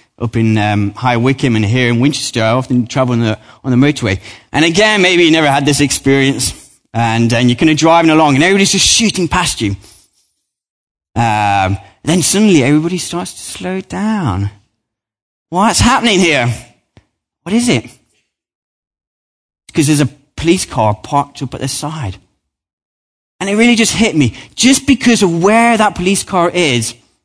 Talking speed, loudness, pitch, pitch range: 165 wpm, -12 LUFS, 135 Hz, 110-175 Hz